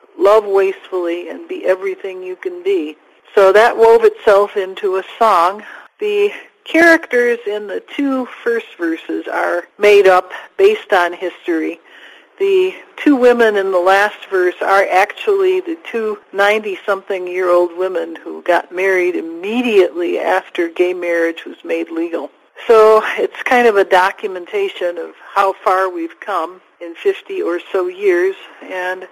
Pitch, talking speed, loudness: 210 Hz, 145 wpm, -15 LUFS